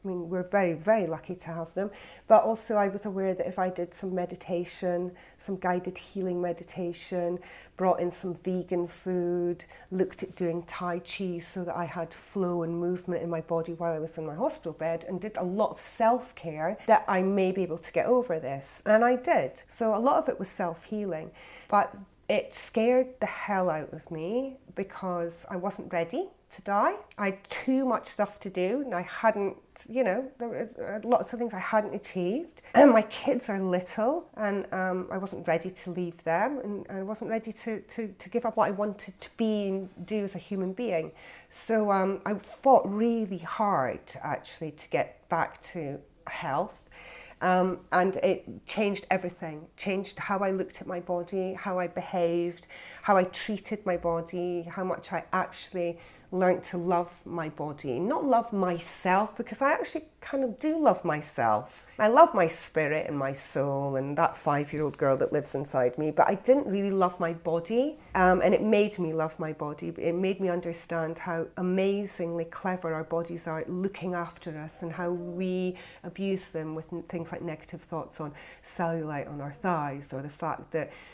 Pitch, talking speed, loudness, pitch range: 180 Hz, 195 wpm, -29 LUFS, 170-205 Hz